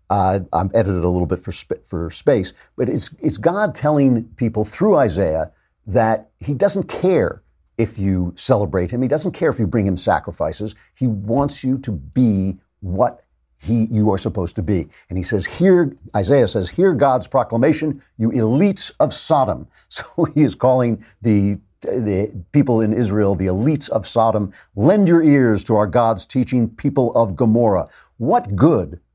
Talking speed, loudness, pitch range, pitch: 175 wpm, -18 LUFS, 95-130 Hz, 110 Hz